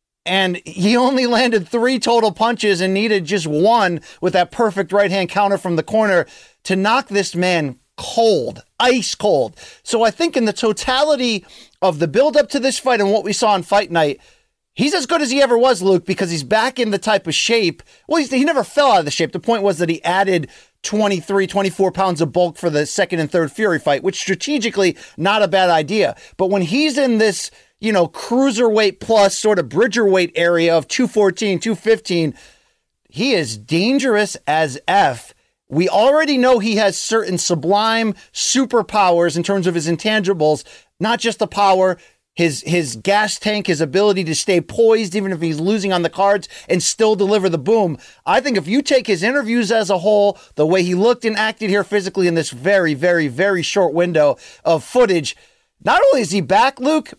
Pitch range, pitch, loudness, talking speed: 180-230 Hz, 200 Hz, -16 LUFS, 195 wpm